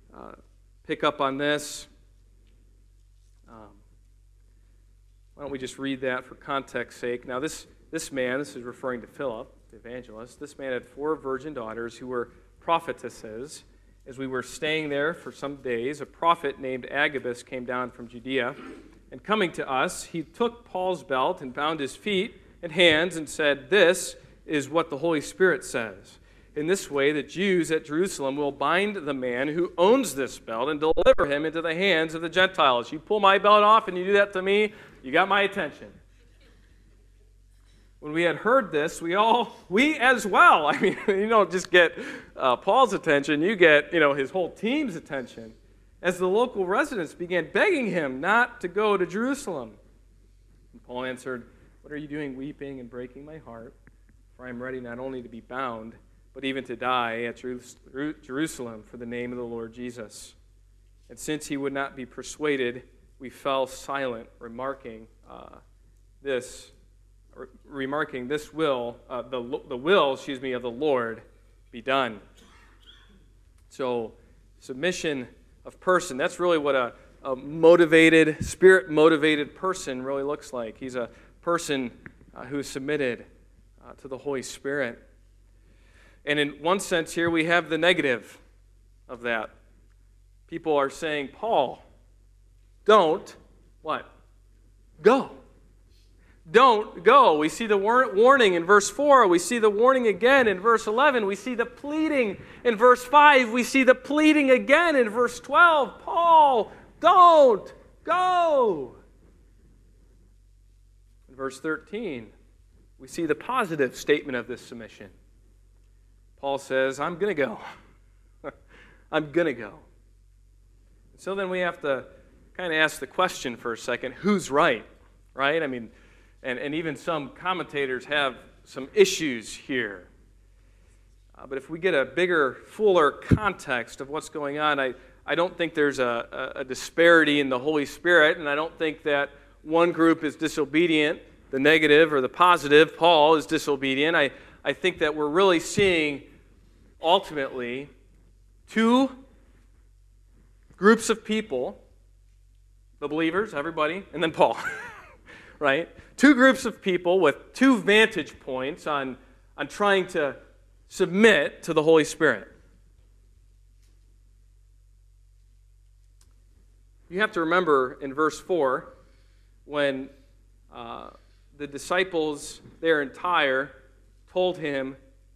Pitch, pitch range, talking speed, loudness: 135 Hz, 105-170 Hz, 150 wpm, -24 LUFS